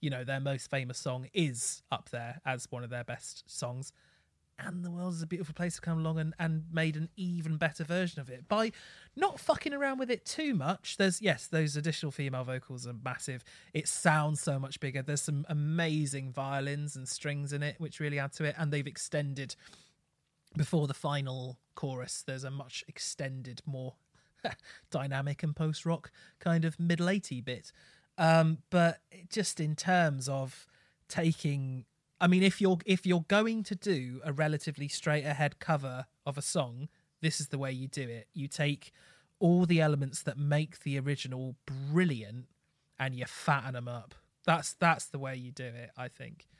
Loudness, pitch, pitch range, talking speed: -33 LUFS, 150 Hz, 135-165 Hz, 185 wpm